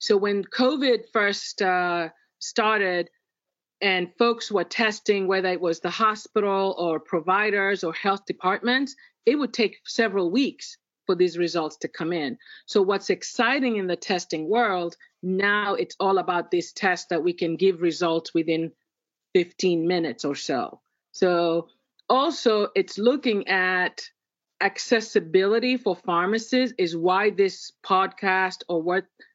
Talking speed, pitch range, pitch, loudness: 140 wpm, 175-225 Hz, 195 Hz, -24 LUFS